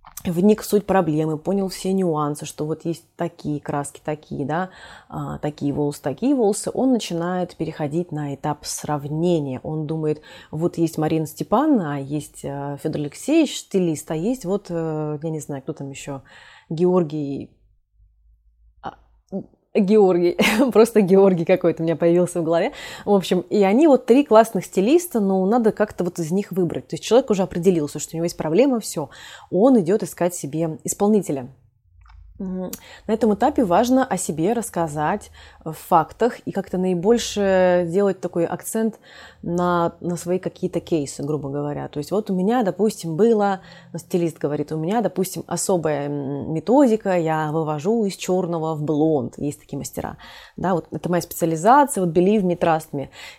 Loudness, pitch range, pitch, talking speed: -21 LUFS, 155-200 Hz, 175 Hz, 155 wpm